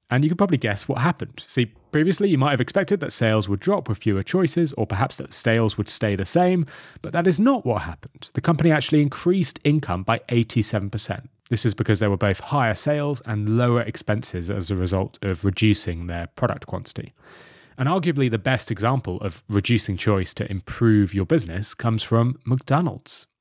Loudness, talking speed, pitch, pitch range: -22 LUFS, 190 wpm, 115 Hz, 105-145 Hz